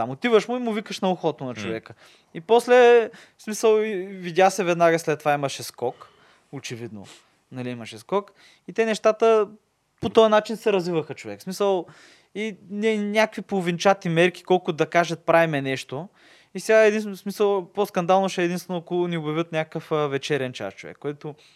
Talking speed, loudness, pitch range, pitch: 170 wpm, -22 LUFS, 150-210 Hz, 180 Hz